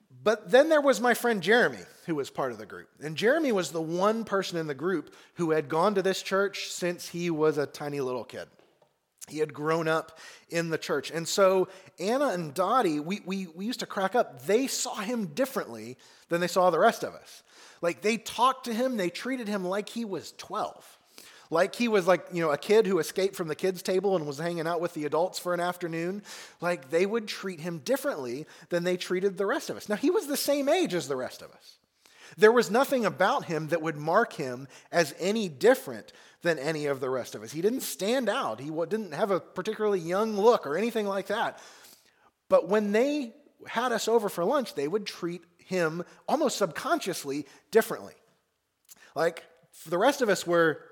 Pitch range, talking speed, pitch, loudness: 170-225 Hz, 210 wpm, 190 Hz, -28 LUFS